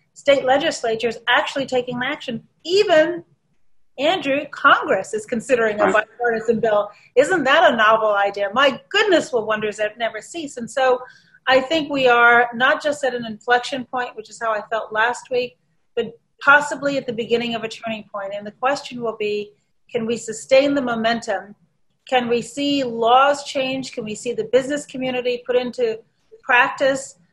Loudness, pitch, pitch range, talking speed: -19 LUFS, 245 Hz, 220-275 Hz, 170 wpm